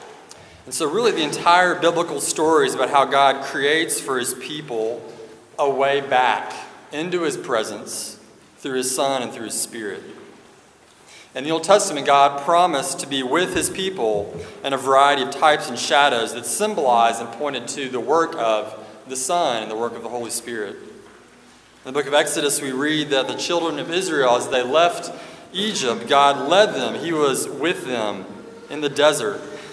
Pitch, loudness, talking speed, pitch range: 140 Hz, -20 LUFS, 180 wpm, 125-165 Hz